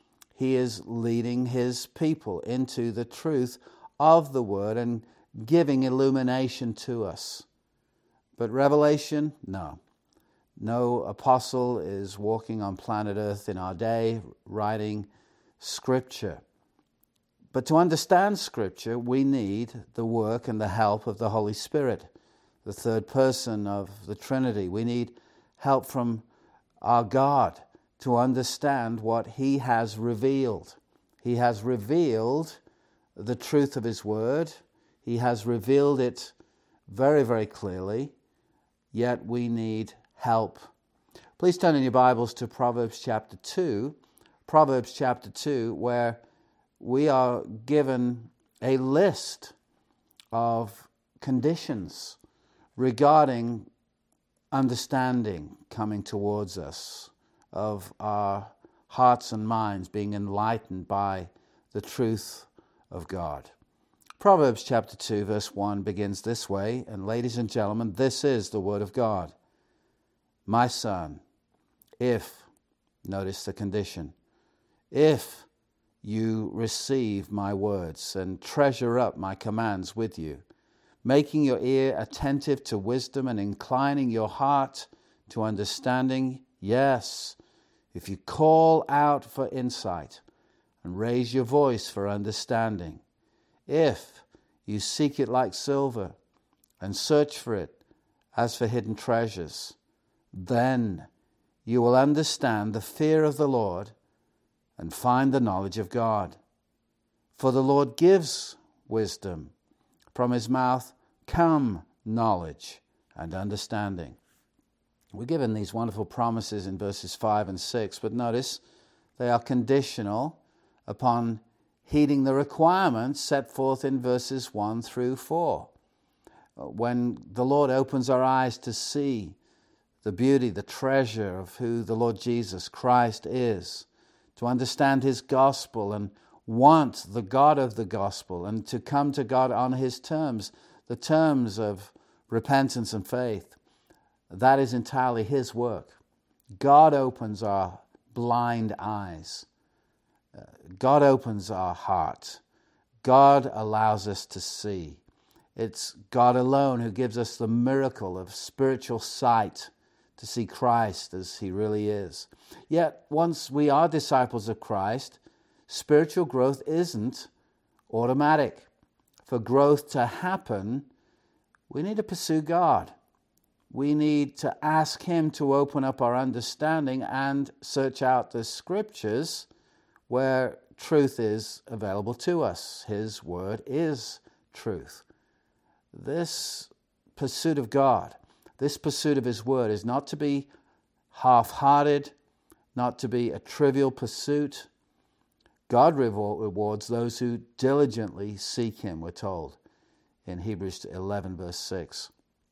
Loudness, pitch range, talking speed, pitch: -27 LUFS, 105-135 Hz, 120 wpm, 120 Hz